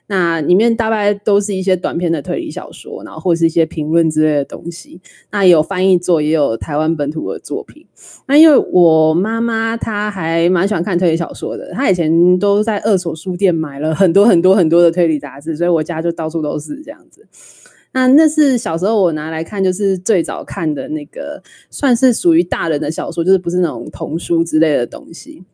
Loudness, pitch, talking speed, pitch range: -15 LUFS, 180 Hz, 315 characters per minute, 165-210 Hz